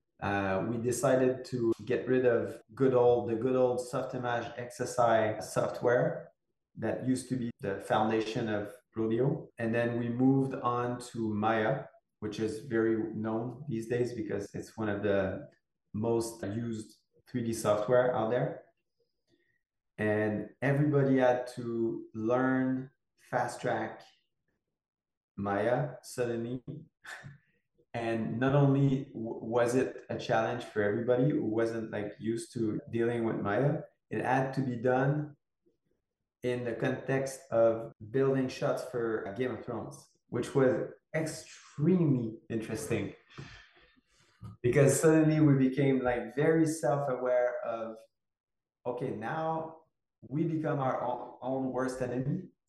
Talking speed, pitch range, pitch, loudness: 125 wpm, 115-135 Hz, 125 Hz, -31 LUFS